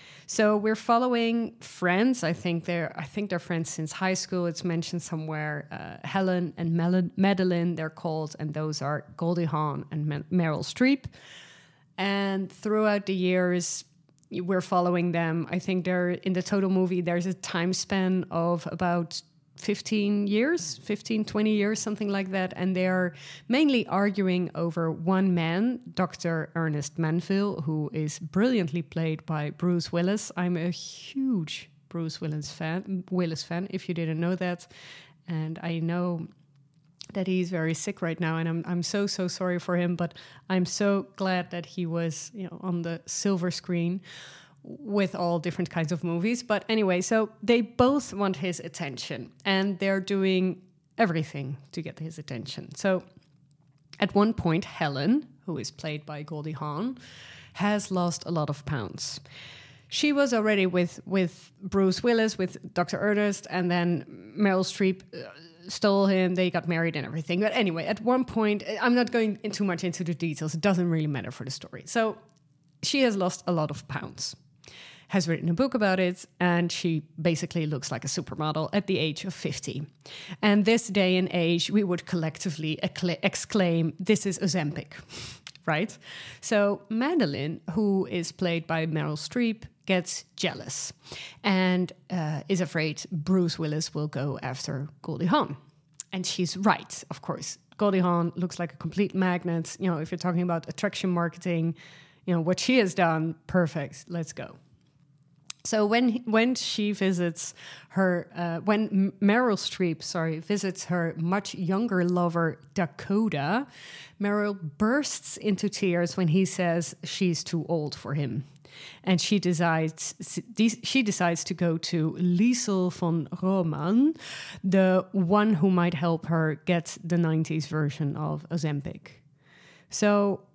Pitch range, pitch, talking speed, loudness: 160-195 Hz, 175 Hz, 160 wpm, -27 LUFS